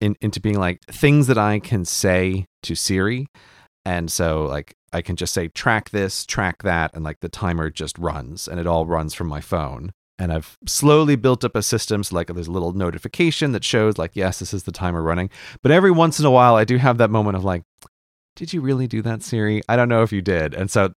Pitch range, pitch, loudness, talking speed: 85-115 Hz, 95 Hz, -20 LUFS, 235 wpm